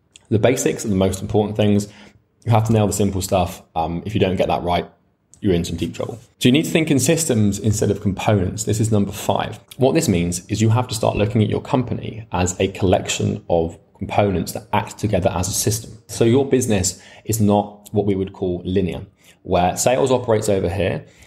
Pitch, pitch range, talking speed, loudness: 100 Hz, 95-110 Hz, 220 wpm, -19 LUFS